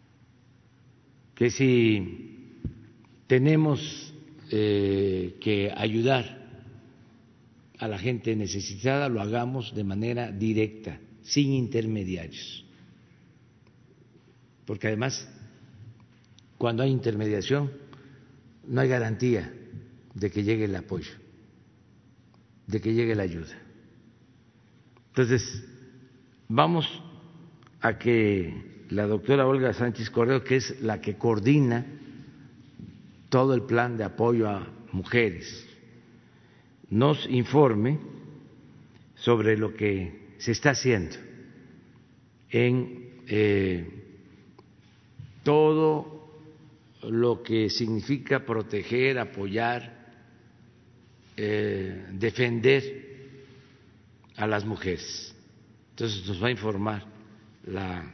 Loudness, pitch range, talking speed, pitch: -27 LUFS, 110-130 Hz, 85 wpm, 115 Hz